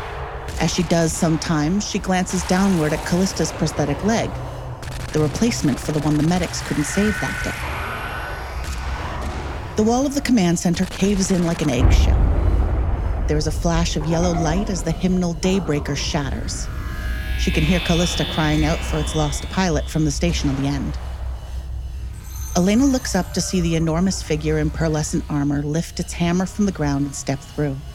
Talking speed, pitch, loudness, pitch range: 175 wpm, 155 Hz, -21 LUFS, 125-180 Hz